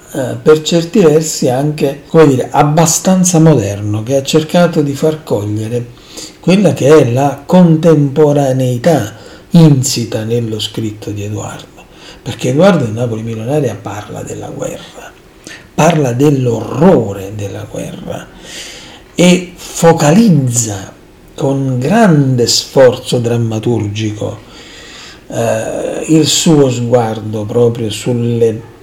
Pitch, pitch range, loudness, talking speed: 130 Hz, 115-155 Hz, -11 LUFS, 100 wpm